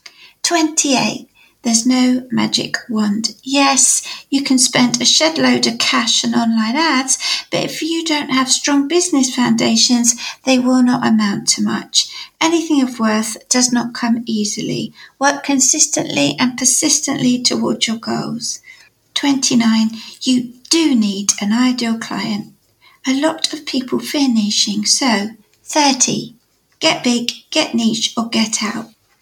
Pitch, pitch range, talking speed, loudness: 250 Hz, 225-285 Hz, 140 wpm, -15 LUFS